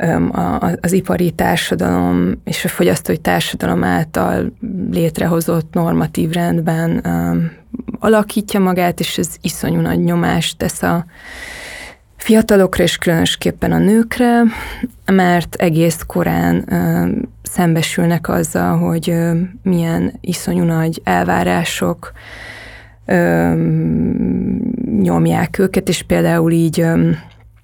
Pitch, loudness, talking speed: 170 Hz, -15 LUFS, 85 wpm